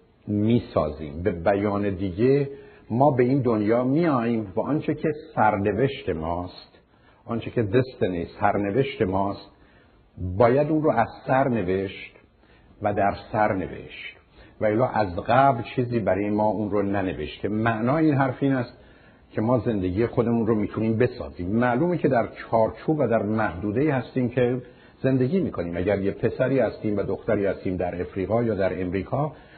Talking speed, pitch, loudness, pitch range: 145 wpm, 110 Hz, -24 LUFS, 100-130 Hz